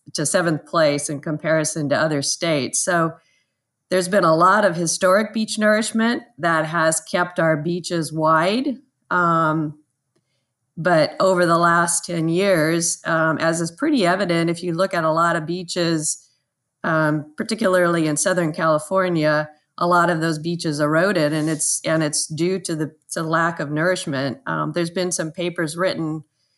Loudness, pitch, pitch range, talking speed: -20 LUFS, 165 Hz, 155-180 Hz, 165 wpm